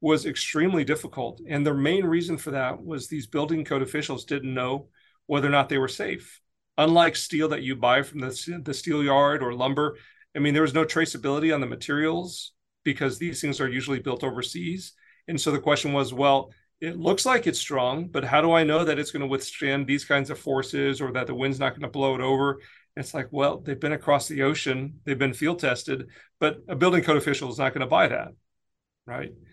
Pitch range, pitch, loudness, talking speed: 135-155 Hz, 145 Hz, -25 LUFS, 225 wpm